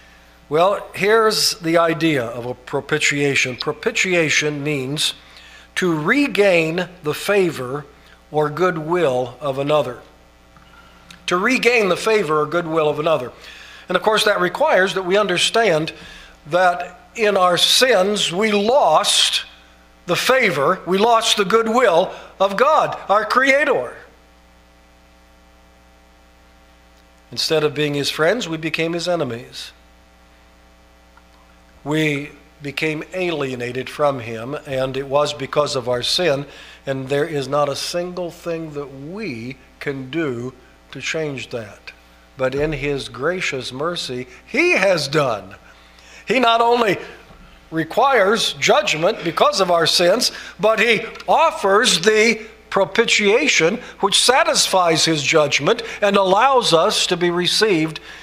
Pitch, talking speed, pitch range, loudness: 155 Hz, 120 wpm, 125-185 Hz, -17 LUFS